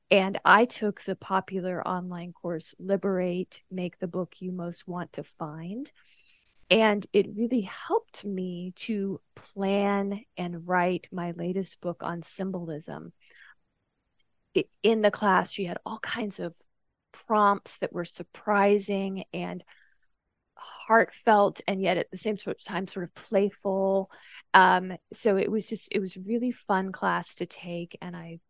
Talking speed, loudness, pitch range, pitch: 145 wpm, -27 LUFS, 180-205 Hz, 190 Hz